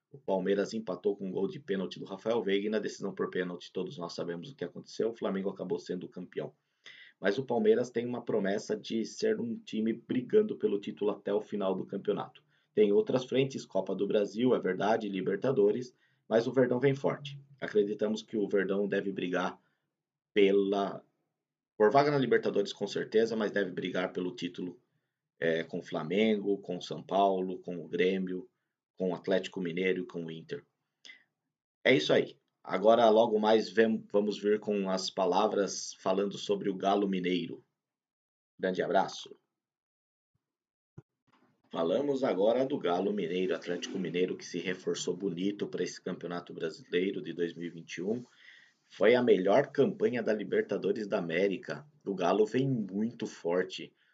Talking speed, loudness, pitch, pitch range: 160 wpm, -31 LUFS, 100 Hz, 90-115 Hz